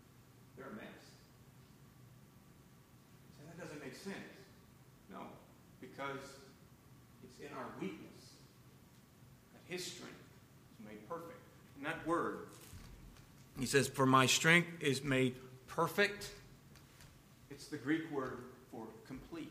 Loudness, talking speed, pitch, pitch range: -37 LUFS, 105 wpm, 135 Hz, 130-155 Hz